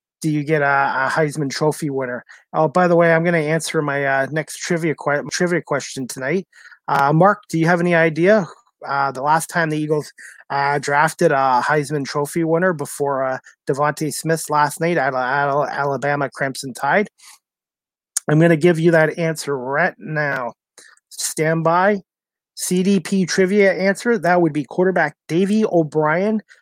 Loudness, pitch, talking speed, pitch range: -18 LUFS, 155 Hz, 165 wpm, 145-175 Hz